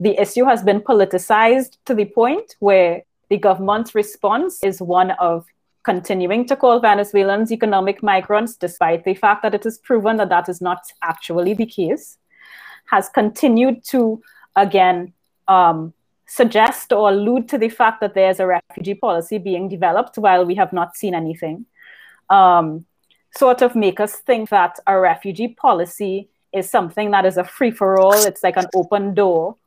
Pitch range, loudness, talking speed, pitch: 185-225 Hz, -17 LUFS, 170 wpm, 200 Hz